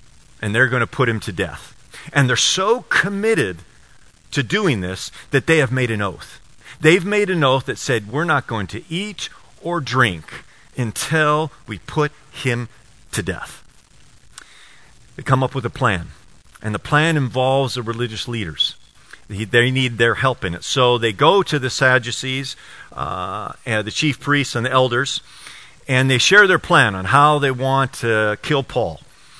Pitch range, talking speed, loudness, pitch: 115-150 Hz, 175 wpm, -18 LUFS, 130 Hz